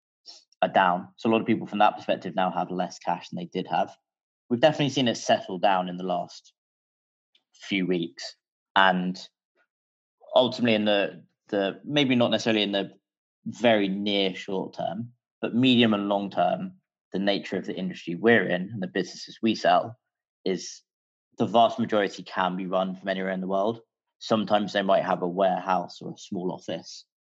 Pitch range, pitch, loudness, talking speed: 95-115 Hz, 100 Hz, -26 LUFS, 180 wpm